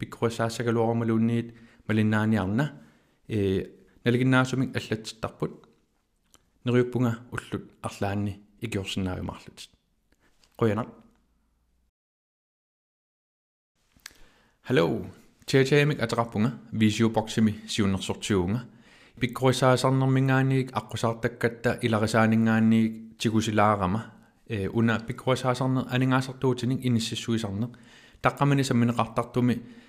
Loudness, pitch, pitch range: -26 LUFS, 115 Hz, 110-125 Hz